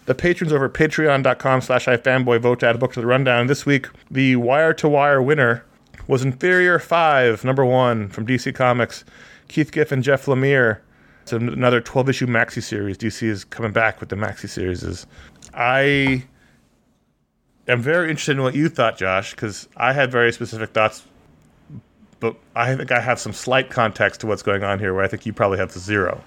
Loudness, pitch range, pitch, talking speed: -19 LUFS, 115-135 Hz, 125 Hz, 190 wpm